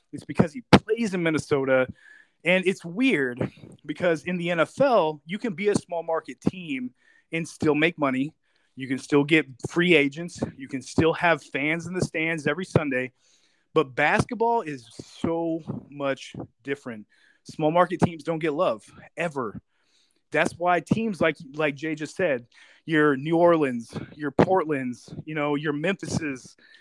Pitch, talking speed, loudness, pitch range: 160 Hz, 155 wpm, -25 LUFS, 145-175 Hz